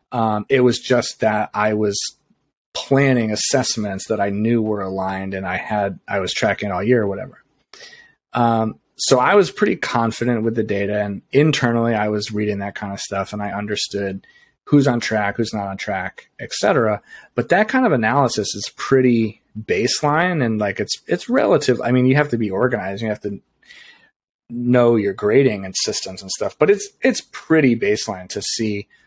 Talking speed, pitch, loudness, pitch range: 185 wpm, 110 Hz, -19 LUFS, 100-125 Hz